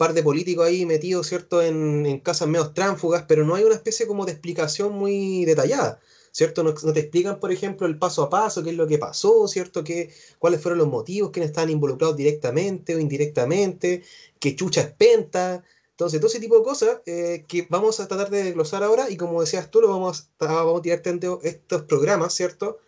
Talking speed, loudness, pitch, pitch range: 210 wpm, -22 LUFS, 175 Hz, 165-195 Hz